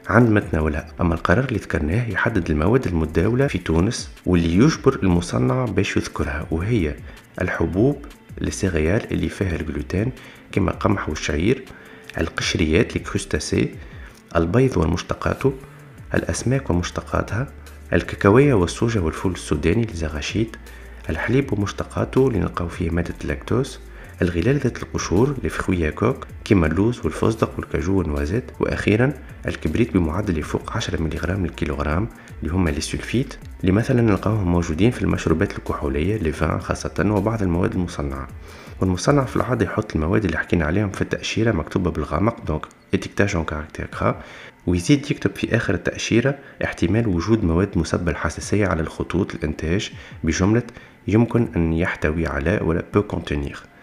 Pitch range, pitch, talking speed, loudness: 80-110 Hz, 90 Hz, 120 wpm, -22 LUFS